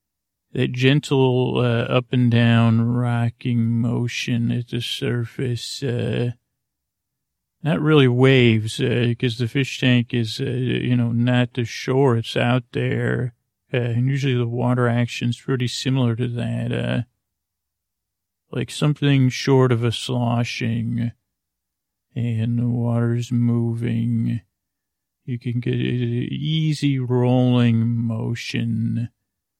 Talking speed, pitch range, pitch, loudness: 120 wpm, 115-125 Hz, 120 Hz, -21 LUFS